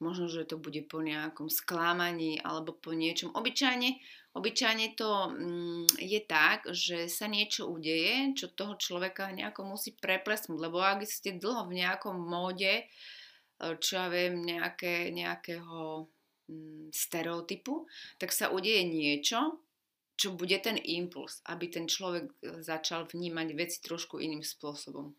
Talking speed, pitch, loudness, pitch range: 130 wpm, 175 Hz, -33 LUFS, 165-200 Hz